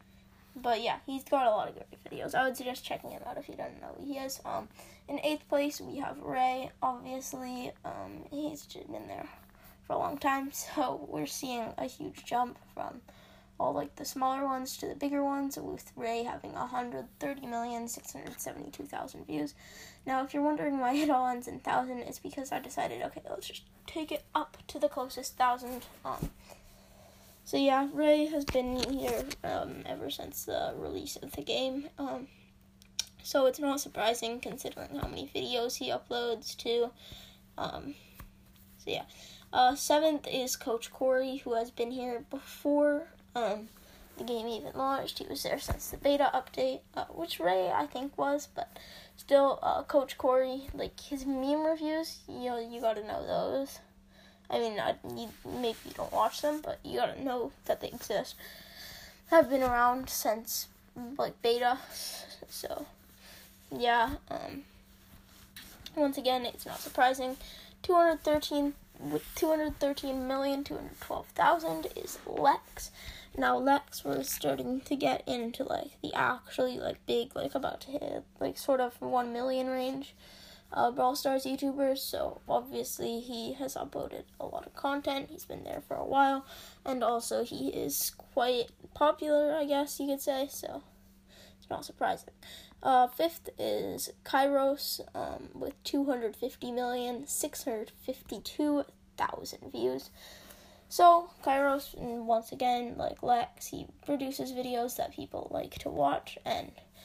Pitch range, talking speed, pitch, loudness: 245-295 Hz, 155 wpm, 270 Hz, -33 LUFS